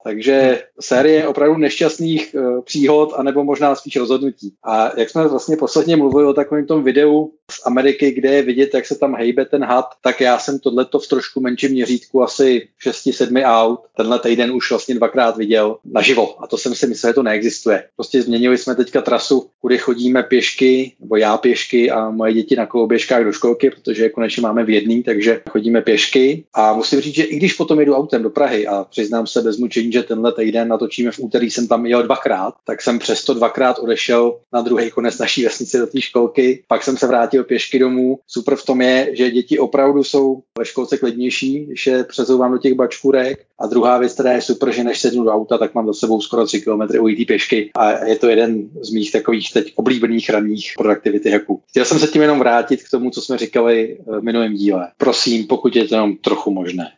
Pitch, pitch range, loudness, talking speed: 125 Hz, 115-135 Hz, -16 LUFS, 205 wpm